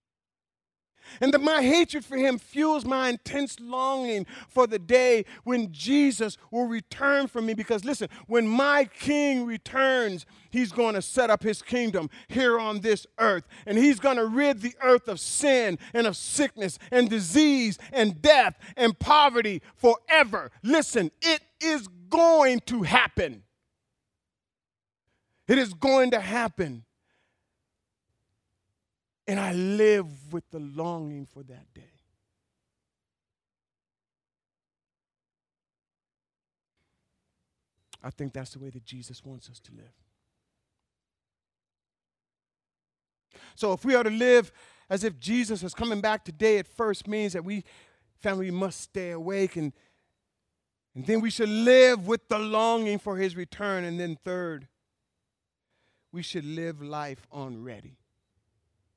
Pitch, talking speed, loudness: 210 Hz, 130 wpm, -25 LUFS